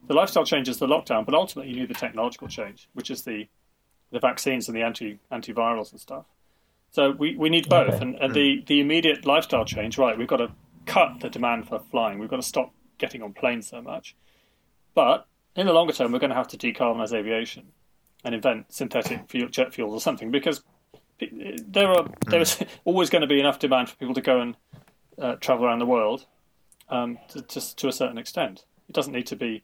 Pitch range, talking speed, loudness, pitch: 115-155 Hz, 215 wpm, -24 LUFS, 130 Hz